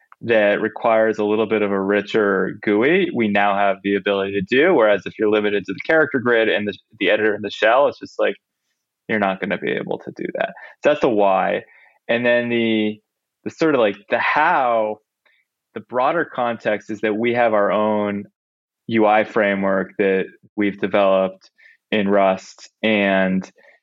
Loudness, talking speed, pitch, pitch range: -19 LUFS, 185 wpm, 105 Hz, 100-110 Hz